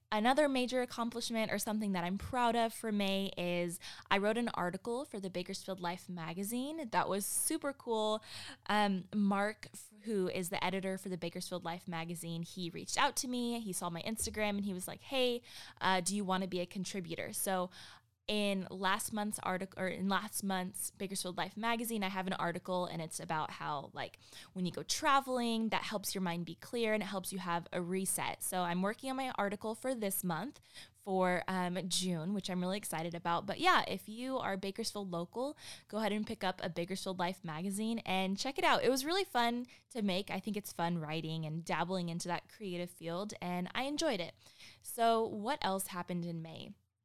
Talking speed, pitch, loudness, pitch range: 205 wpm, 195 Hz, -37 LUFS, 180-220 Hz